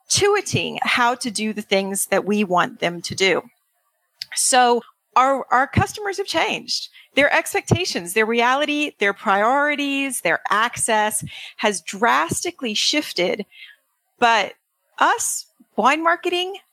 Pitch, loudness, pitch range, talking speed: 250 Hz, -20 LUFS, 215-315 Hz, 120 wpm